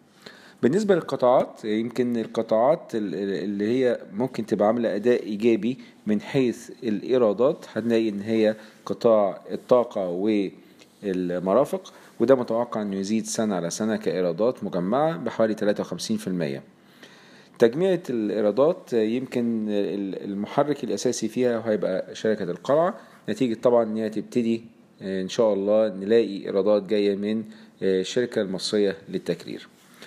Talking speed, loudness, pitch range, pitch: 115 wpm, -24 LUFS, 105-120 Hz, 110 Hz